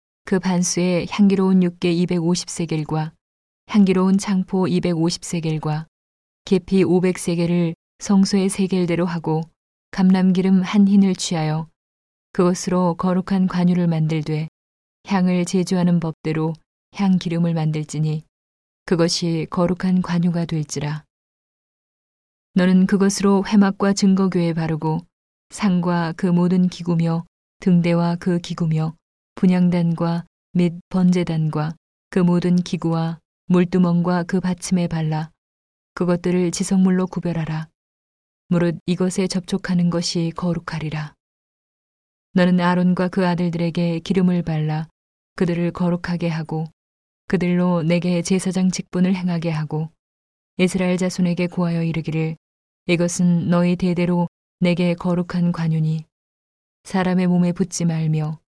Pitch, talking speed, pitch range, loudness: 175 Hz, 260 characters per minute, 160-185 Hz, -20 LUFS